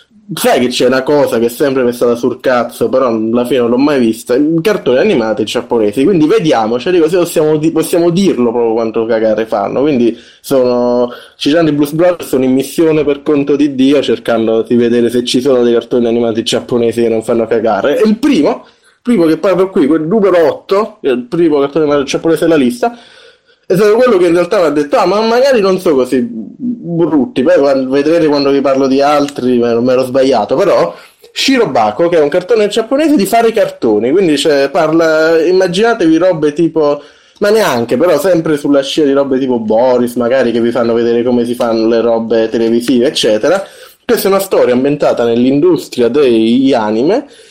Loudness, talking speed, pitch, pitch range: -11 LUFS, 195 wpm, 145 Hz, 120-185 Hz